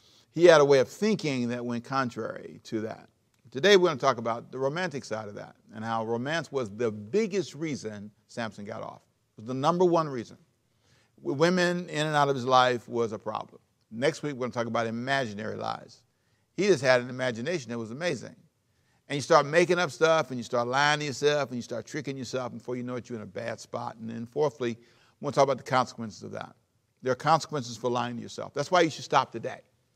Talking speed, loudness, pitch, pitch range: 230 wpm, -27 LUFS, 125 Hz, 115-150 Hz